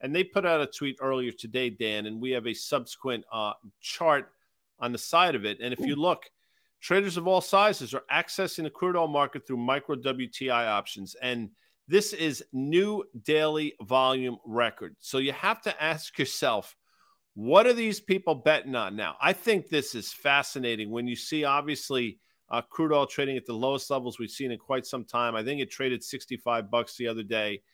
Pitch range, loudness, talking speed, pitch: 120-160 Hz, -28 LUFS, 195 wpm, 135 Hz